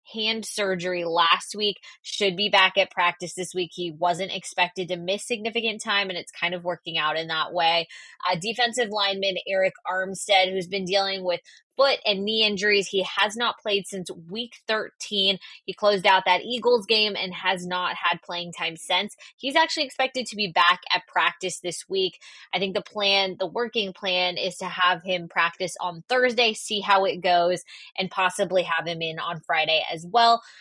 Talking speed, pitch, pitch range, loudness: 190 wpm, 190 Hz, 180-210 Hz, -24 LUFS